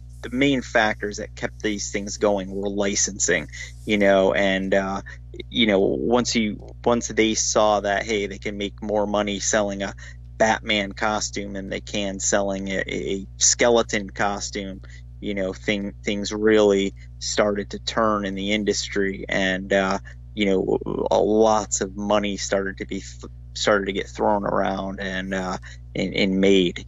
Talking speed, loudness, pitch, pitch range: 160 wpm, -22 LUFS, 100 Hz, 95-105 Hz